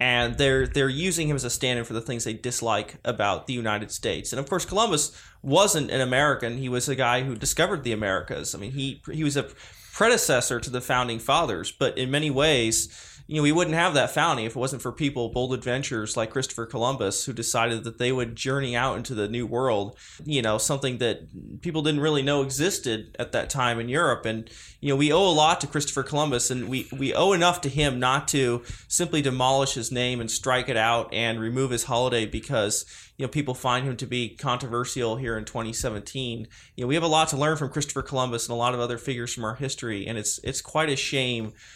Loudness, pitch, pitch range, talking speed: -25 LUFS, 125 Hz, 115-140 Hz, 230 wpm